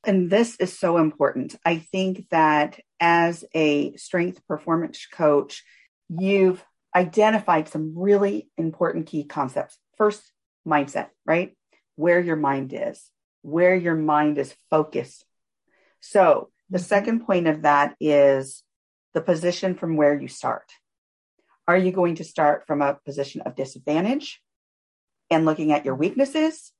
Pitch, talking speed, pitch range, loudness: 165 Hz, 135 wpm, 150-185 Hz, -22 LUFS